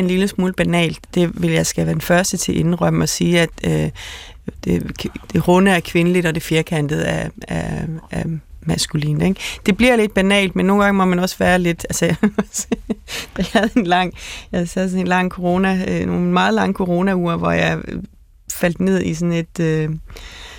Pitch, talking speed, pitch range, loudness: 175 Hz, 190 wpm, 160-190 Hz, -18 LUFS